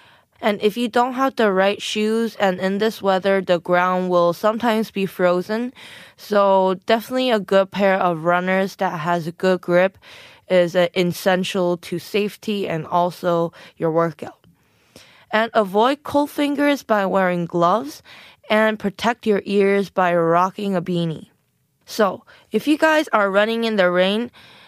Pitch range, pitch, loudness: 180-220 Hz, 195 Hz, -19 LUFS